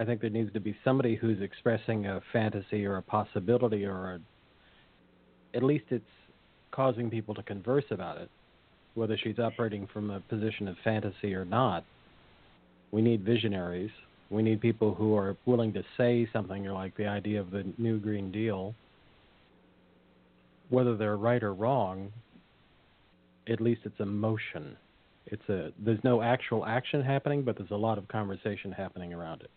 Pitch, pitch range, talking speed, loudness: 105 Hz, 95-115 Hz, 165 wpm, -31 LUFS